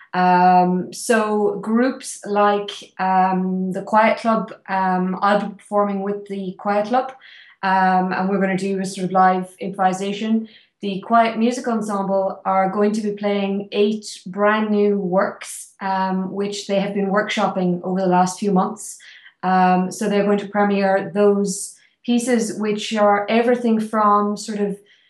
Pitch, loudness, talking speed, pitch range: 200 Hz, -19 LUFS, 155 wpm, 190-210 Hz